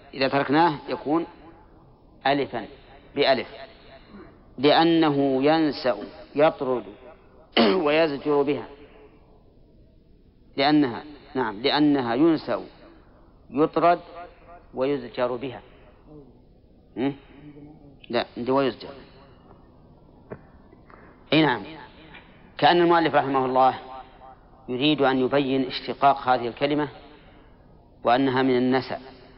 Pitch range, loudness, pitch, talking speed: 130-150 Hz, -23 LUFS, 135 Hz, 70 wpm